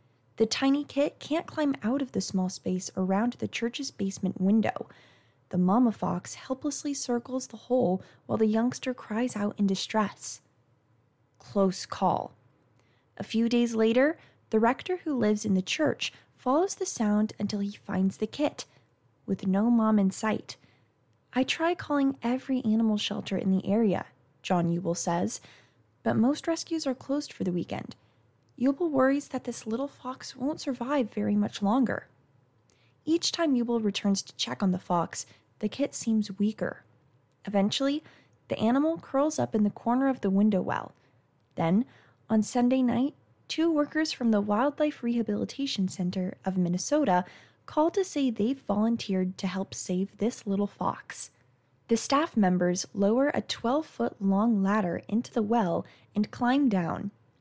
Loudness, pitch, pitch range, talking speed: -28 LUFS, 215 Hz, 185-260 Hz, 155 wpm